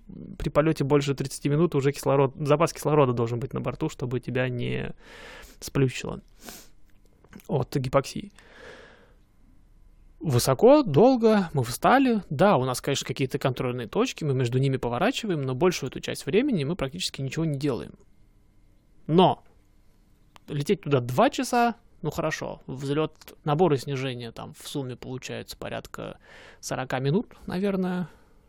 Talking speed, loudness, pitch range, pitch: 130 wpm, -25 LUFS, 125-170 Hz, 140 Hz